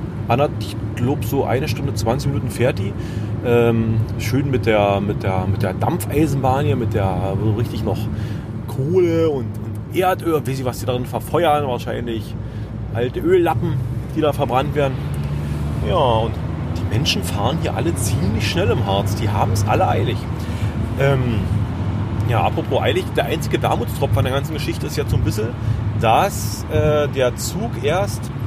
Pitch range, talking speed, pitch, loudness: 105-130 Hz, 160 wpm, 115 Hz, -20 LUFS